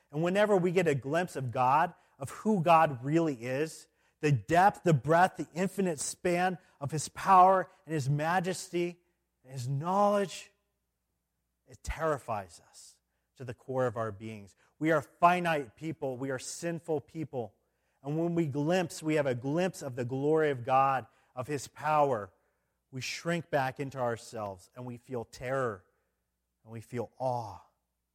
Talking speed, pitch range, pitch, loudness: 160 wpm, 125-170 Hz, 145 Hz, -30 LUFS